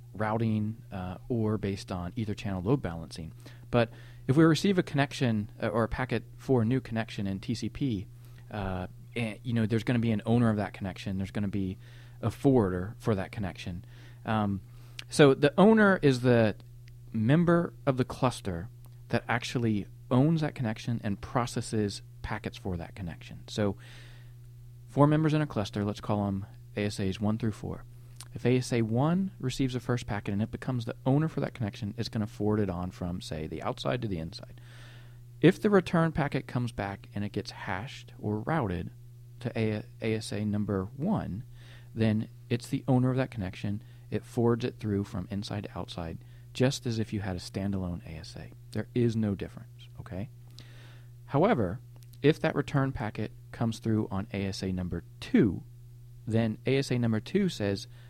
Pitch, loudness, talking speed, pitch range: 120 Hz, -30 LUFS, 175 wpm, 105-125 Hz